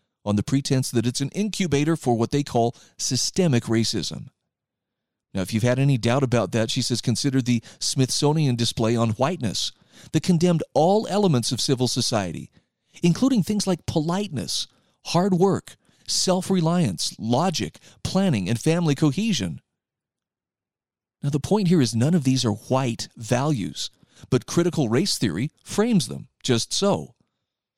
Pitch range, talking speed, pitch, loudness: 120-175 Hz, 145 wpm, 135 Hz, -23 LUFS